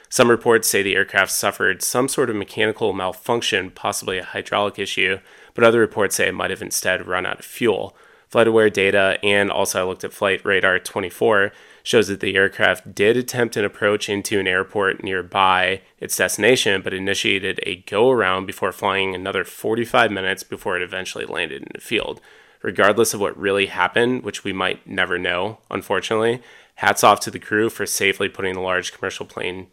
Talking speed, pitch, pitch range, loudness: 180 wpm, 100 Hz, 95-120 Hz, -19 LUFS